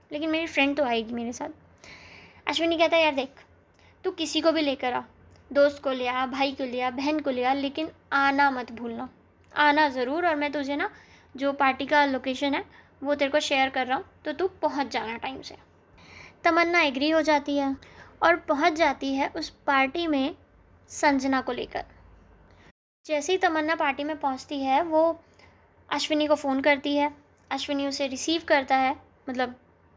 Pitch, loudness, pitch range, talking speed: 285 Hz, -26 LUFS, 270-310 Hz, 185 wpm